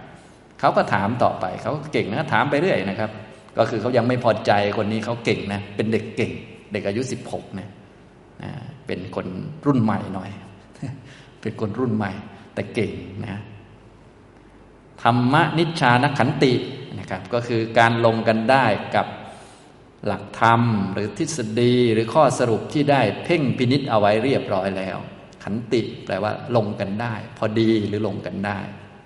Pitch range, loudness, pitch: 105-125 Hz, -21 LUFS, 110 Hz